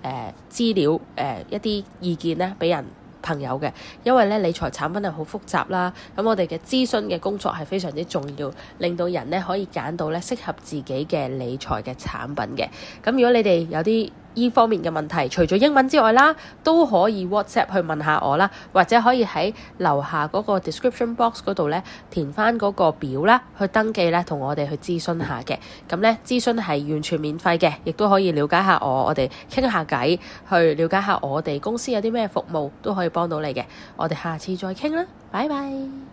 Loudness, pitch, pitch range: -22 LUFS, 180 Hz, 160-220 Hz